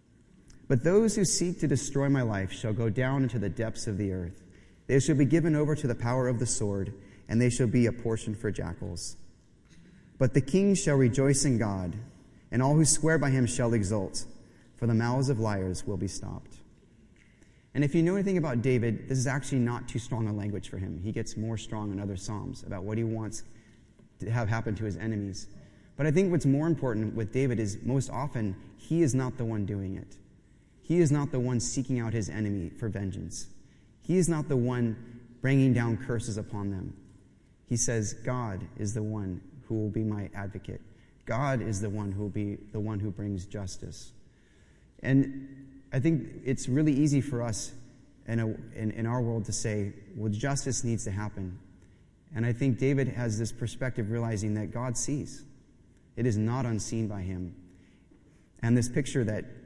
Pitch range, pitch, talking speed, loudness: 105-130 Hz, 115 Hz, 200 wpm, -30 LUFS